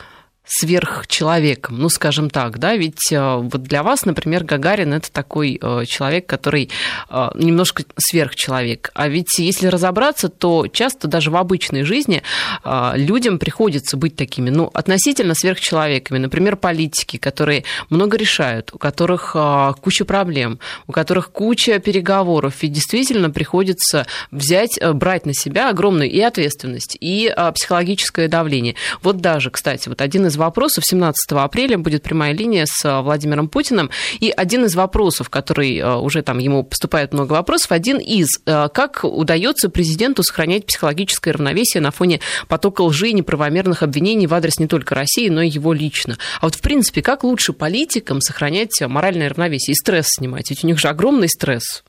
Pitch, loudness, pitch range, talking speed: 165 Hz, -16 LUFS, 145-185 Hz, 150 wpm